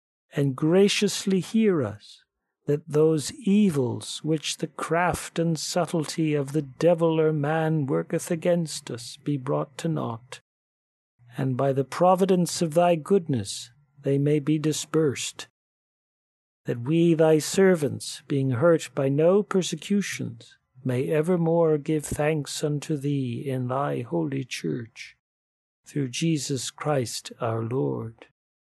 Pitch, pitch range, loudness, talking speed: 150 Hz, 135-170 Hz, -25 LUFS, 125 wpm